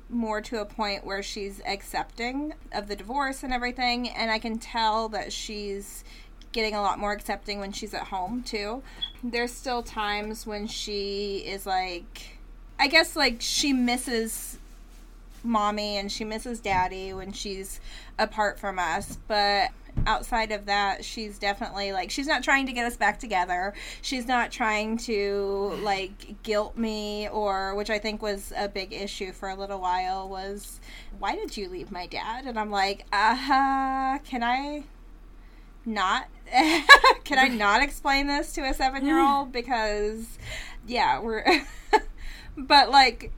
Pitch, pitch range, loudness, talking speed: 215 Hz, 200-250 Hz, -26 LUFS, 155 wpm